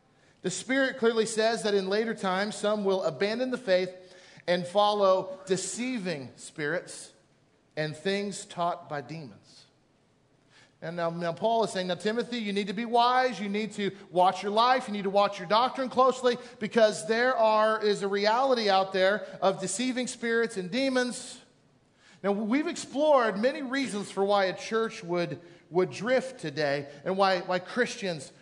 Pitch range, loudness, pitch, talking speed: 180-235 Hz, -28 LUFS, 200 Hz, 165 wpm